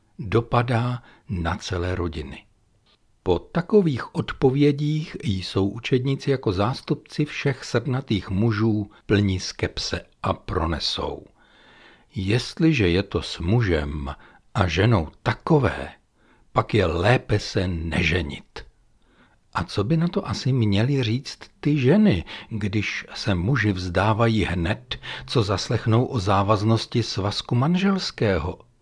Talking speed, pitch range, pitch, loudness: 110 wpm, 95-130 Hz, 110 Hz, -23 LUFS